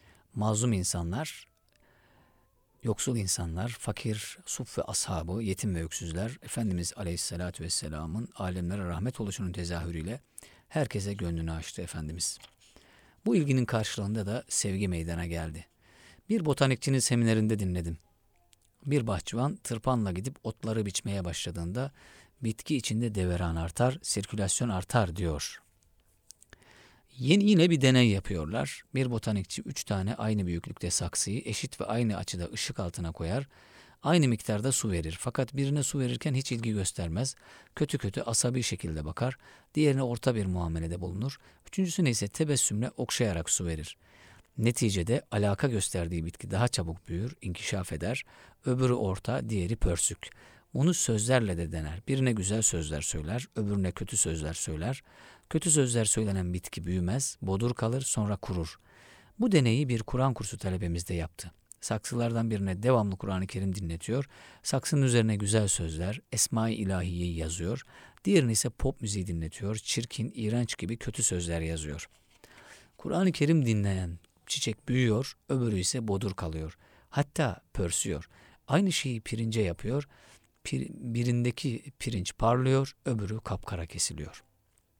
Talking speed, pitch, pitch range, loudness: 125 wpm, 110 Hz, 90-125 Hz, -30 LUFS